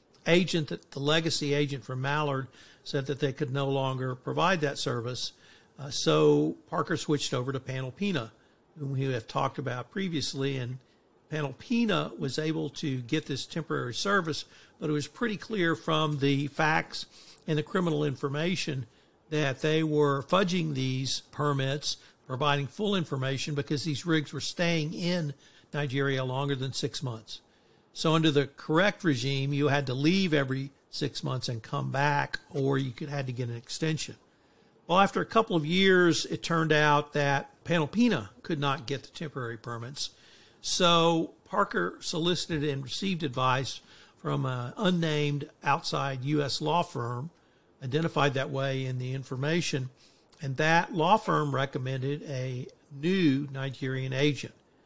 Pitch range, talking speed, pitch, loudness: 135-160 Hz, 150 wpm, 145 Hz, -29 LUFS